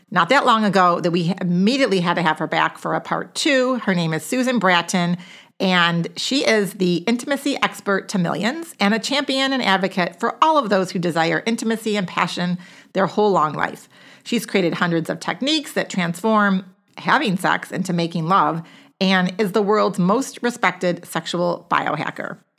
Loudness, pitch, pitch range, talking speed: -20 LUFS, 195 Hz, 175-225 Hz, 180 wpm